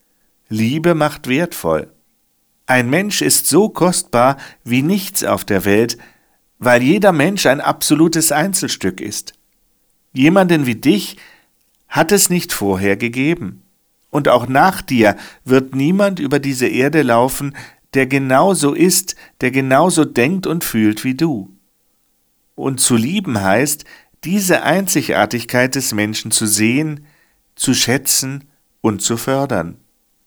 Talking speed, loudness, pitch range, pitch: 125 wpm, -15 LUFS, 120-160 Hz, 135 Hz